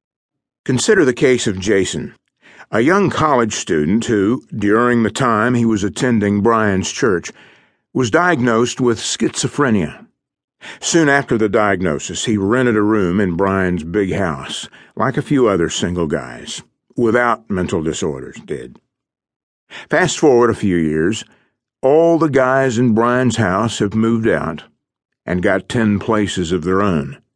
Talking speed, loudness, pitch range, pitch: 145 wpm, -16 LUFS, 100-120 Hz, 110 Hz